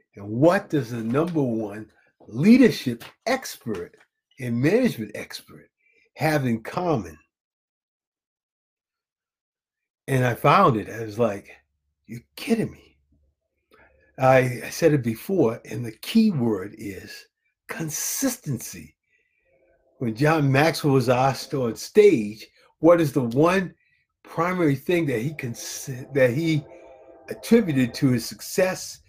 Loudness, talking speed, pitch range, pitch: -22 LUFS, 120 wpm, 115-165 Hz, 140 Hz